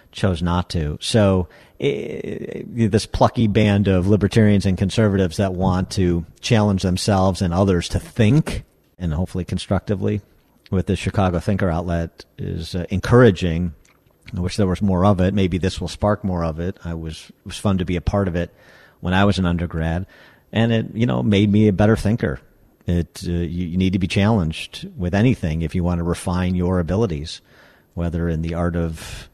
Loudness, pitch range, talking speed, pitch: -20 LUFS, 85-105 Hz, 190 wpm, 95 Hz